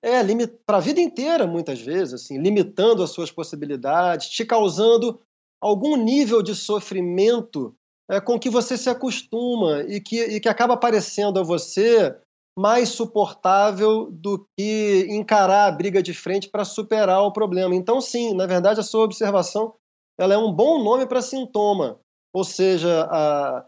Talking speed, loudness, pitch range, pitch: 160 wpm, -21 LUFS, 190-230 Hz, 210 Hz